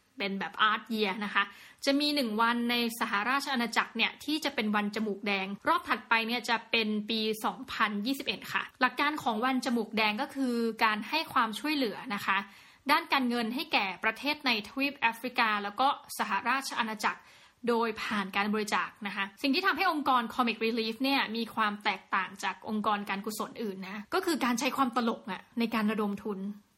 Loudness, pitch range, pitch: -30 LUFS, 210-260 Hz, 230 Hz